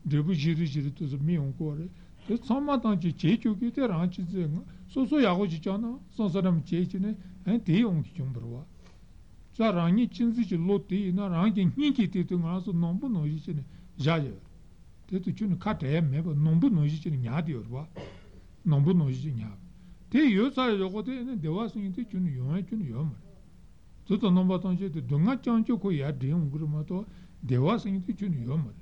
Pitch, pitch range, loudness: 180 Hz, 155-210 Hz, -29 LUFS